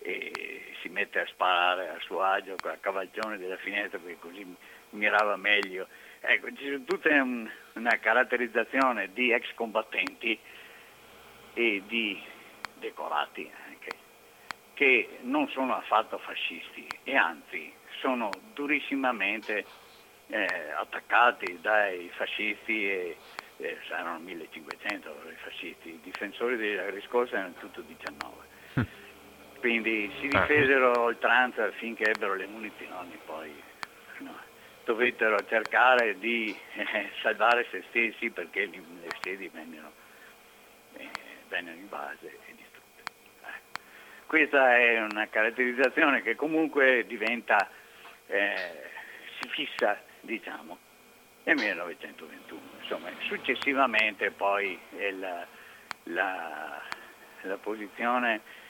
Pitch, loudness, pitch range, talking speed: 120 Hz, -28 LUFS, 110-145 Hz, 105 wpm